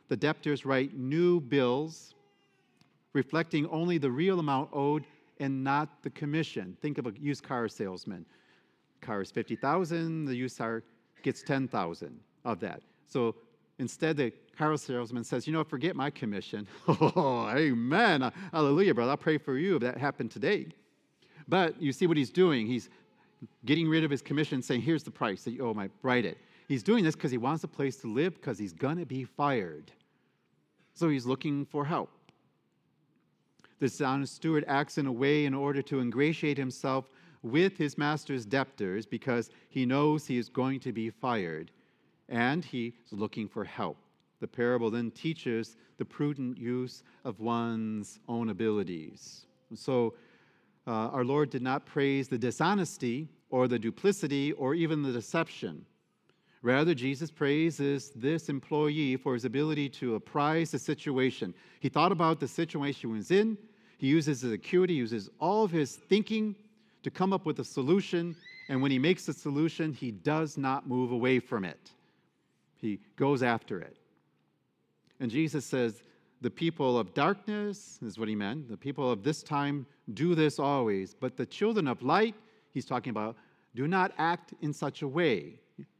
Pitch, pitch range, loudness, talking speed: 140 Hz, 125-160 Hz, -31 LUFS, 170 wpm